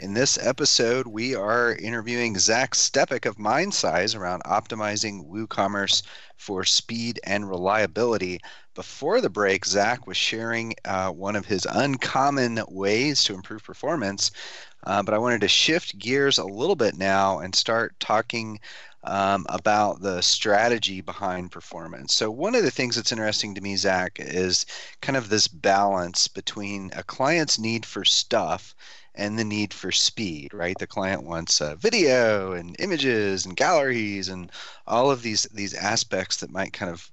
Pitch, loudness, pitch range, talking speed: 105 Hz, -23 LUFS, 95-115 Hz, 160 wpm